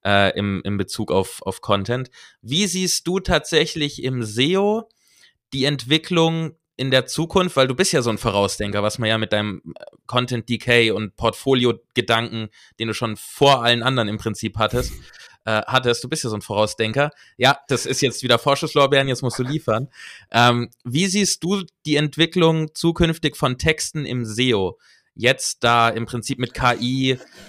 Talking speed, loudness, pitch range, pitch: 170 wpm, -20 LUFS, 115-155 Hz, 130 Hz